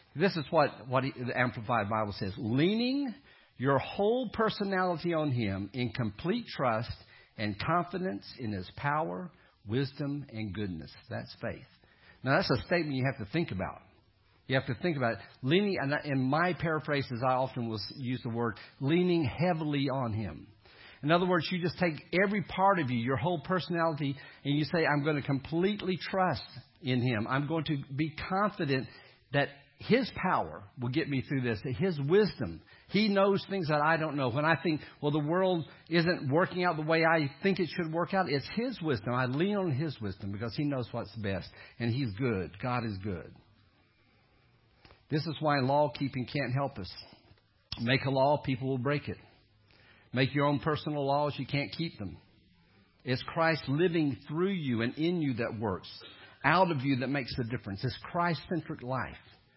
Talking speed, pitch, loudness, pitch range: 185 wpm, 140 Hz, -31 LUFS, 115-165 Hz